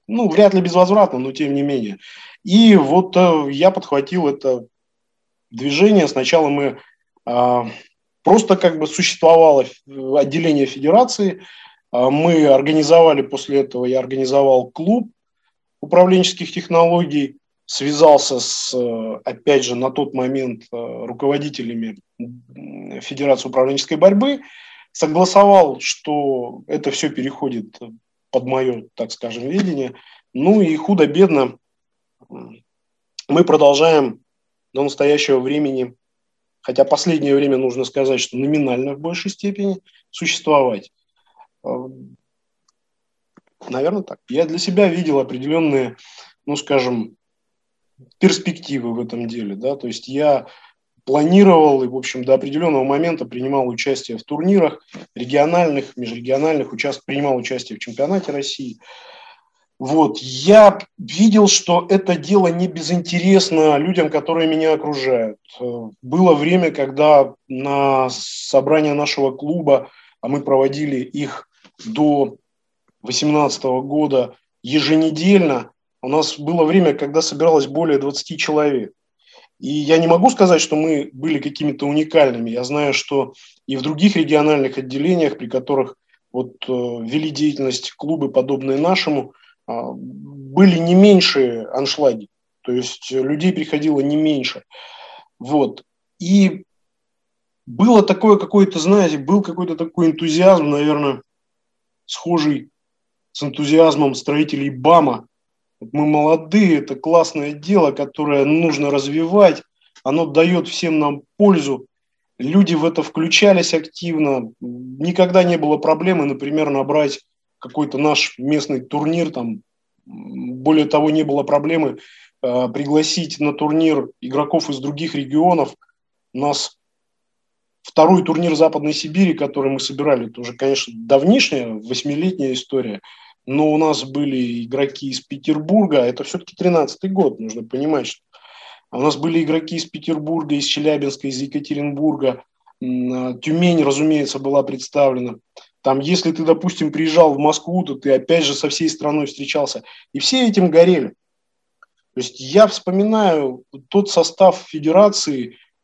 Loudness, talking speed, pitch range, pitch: -16 LUFS, 120 wpm, 135-170 Hz, 150 Hz